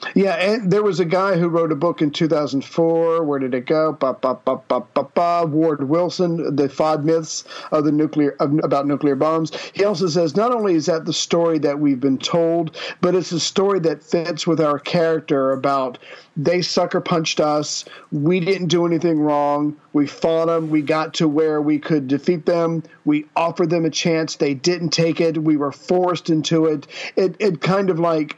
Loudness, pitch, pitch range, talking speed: -19 LUFS, 160 Hz, 150-175 Hz, 200 wpm